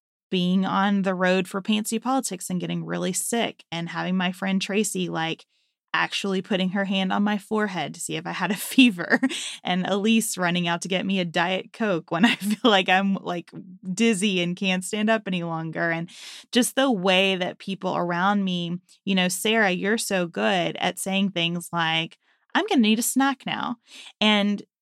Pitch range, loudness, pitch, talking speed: 180-215 Hz, -24 LUFS, 195 Hz, 195 wpm